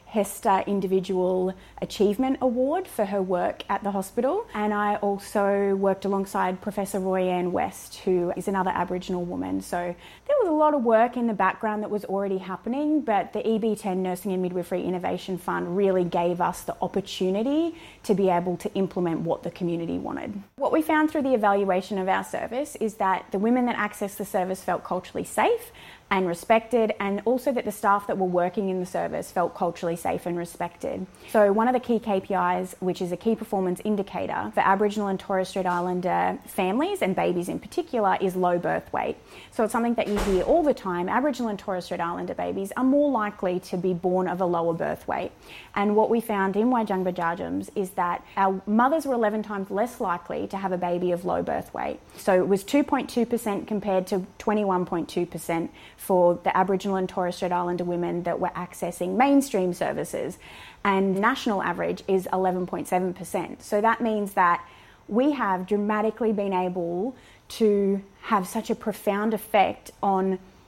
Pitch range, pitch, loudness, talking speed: 185-220 Hz, 195 Hz, -25 LUFS, 185 wpm